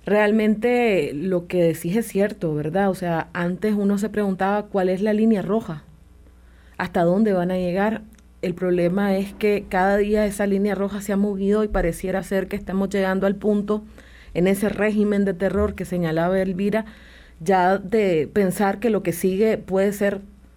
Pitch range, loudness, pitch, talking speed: 185-210 Hz, -22 LUFS, 195 Hz, 175 wpm